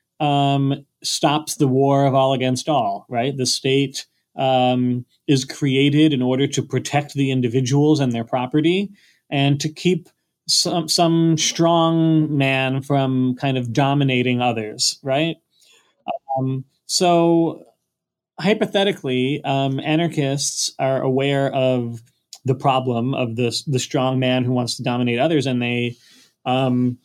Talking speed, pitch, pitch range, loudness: 130 wpm, 135 Hz, 130-155 Hz, -19 LUFS